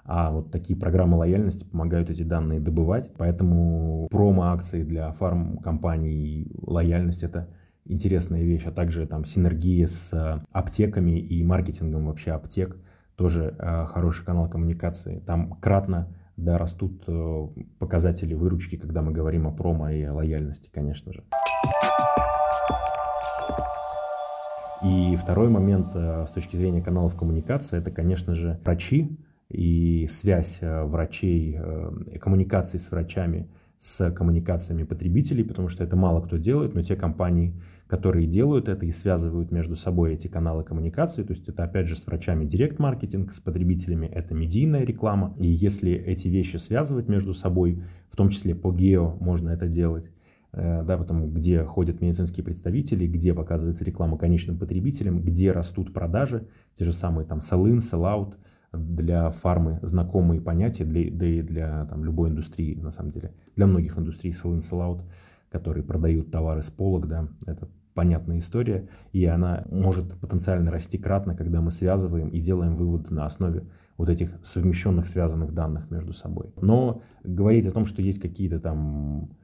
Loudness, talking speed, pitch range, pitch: -25 LUFS, 145 wpm, 85-95 Hz, 85 Hz